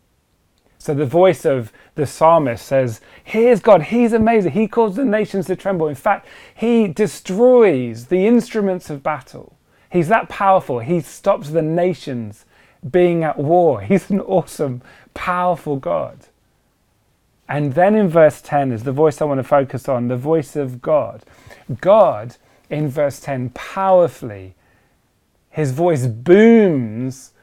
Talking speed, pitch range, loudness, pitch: 140 wpm, 135-195 Hz, -17 LUFS, 160 Hz